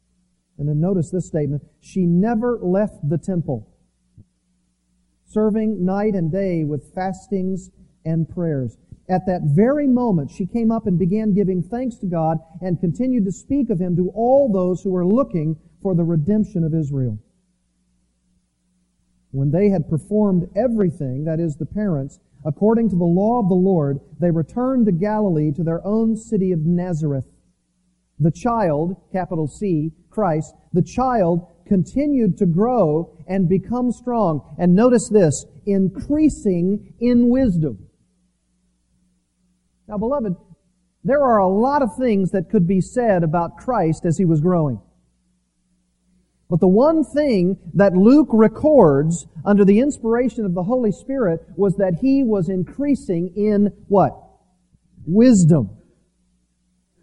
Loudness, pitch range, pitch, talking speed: -19 LUFS, 155-210 Hz, 180 Hz, 140 wpm